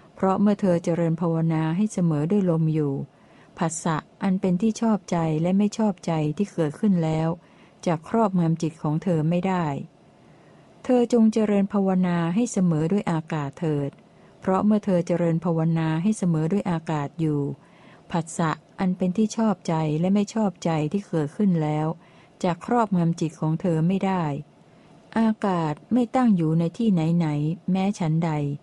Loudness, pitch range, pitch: -24 LUFS, 160-200 Hz, 175 Hz